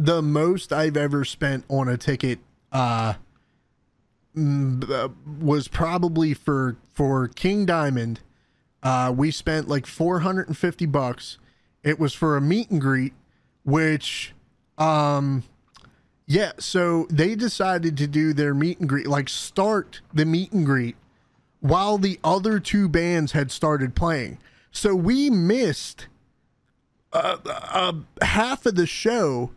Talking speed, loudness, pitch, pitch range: 130 wpm, -23 LUFS, 155 Hz, 135-175 Hz